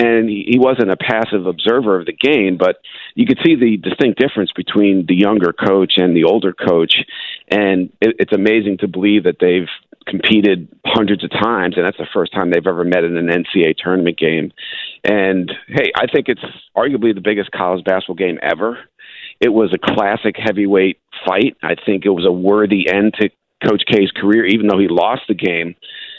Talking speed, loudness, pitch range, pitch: 190 wpm, -15 LUFS, 90-105 Hz, 100 Hz